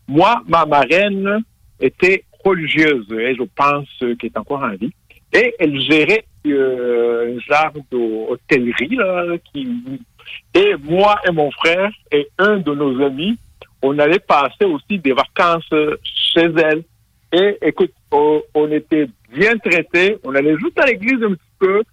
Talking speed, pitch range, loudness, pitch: 150 wpm, 135-200 Hz, -16 LUFS, 155 Hz